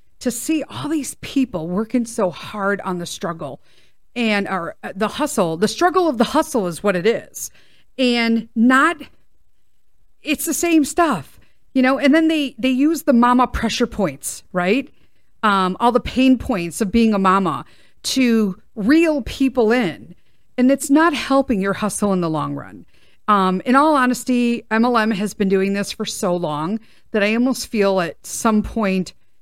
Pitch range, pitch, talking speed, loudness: 195-260 Hz, 225 Hz, 175 wpm, -18 LUFS